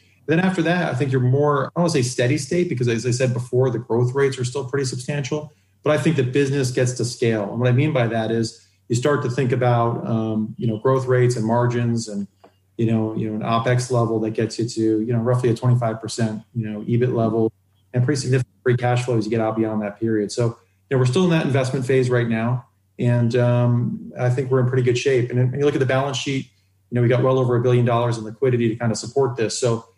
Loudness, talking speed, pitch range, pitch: -21 LUFS, 255 wpm, 115-130 Hz, 120 Hz